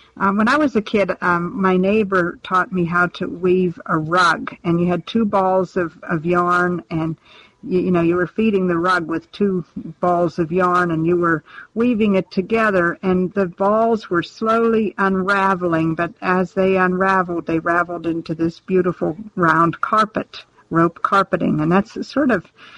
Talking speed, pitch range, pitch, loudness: 175 wpm, 170-195 Hz, 180 Hz, -18 LUFS